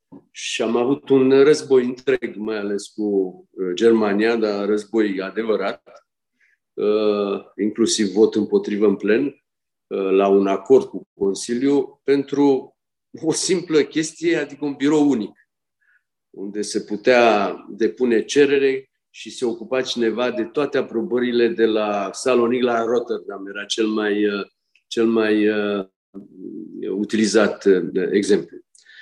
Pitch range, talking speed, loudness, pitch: 105-130 Hz, 115 wpm, -20 LUFS, 110 Hz